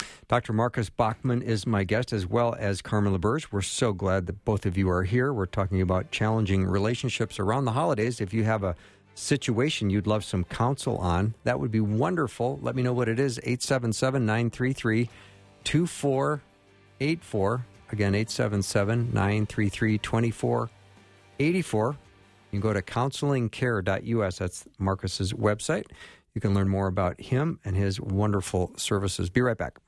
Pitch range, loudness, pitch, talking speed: 100-125 Hz, -27 LUFS, 110 Hz, 145 wpm